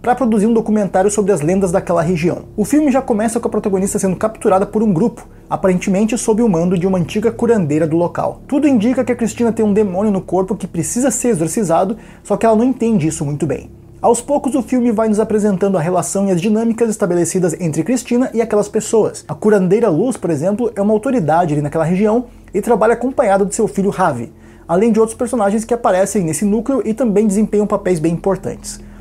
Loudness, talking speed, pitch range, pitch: -15 LUFS, 215 wpm, 185-230 Hz, 210 Hz